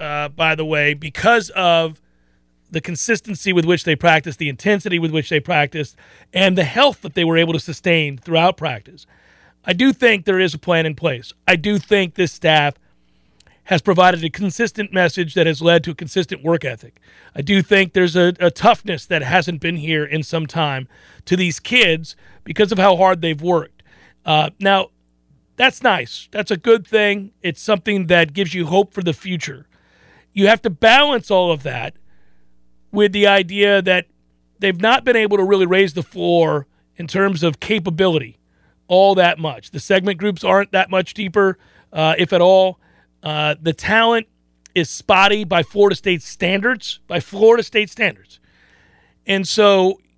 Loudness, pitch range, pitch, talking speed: -16 LUFS, 155-200 Hz, 180 Hz, 180 wpm